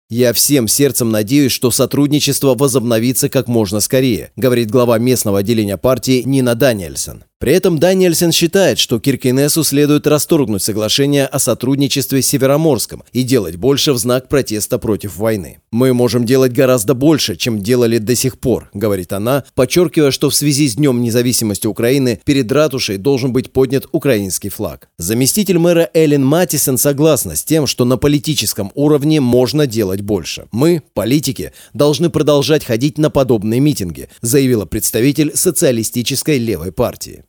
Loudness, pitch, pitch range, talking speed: -14 LUFS, 130 Hz, 115-145 Hz, 150 wpm